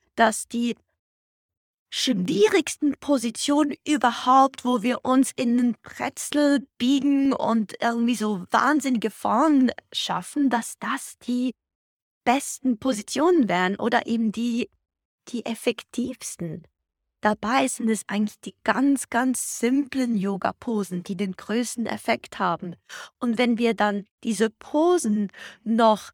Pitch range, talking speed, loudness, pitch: 220-270 Hz, 115 wpm, -24 LUFS, 240 Hz